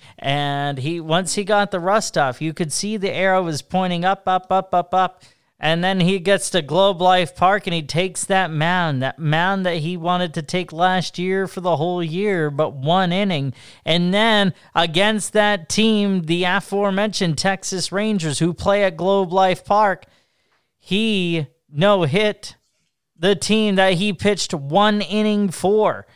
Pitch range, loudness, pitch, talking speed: 170-200 Hz, -19 LUFS, 185 Hz, 170 wpm